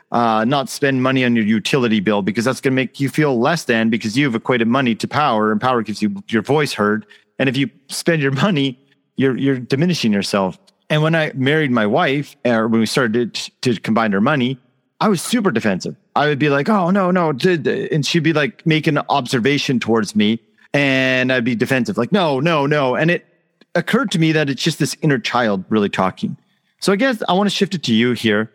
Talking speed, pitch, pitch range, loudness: 225 wpm, 135 Hz, 115-155 Hz, -17 LUFS